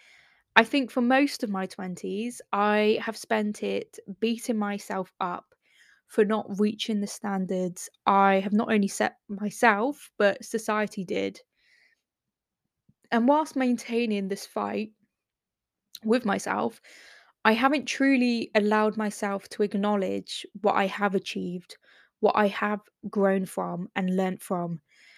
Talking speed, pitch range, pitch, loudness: 130 wpm, 195-230 Hz, 210 Hz, -27 LUFS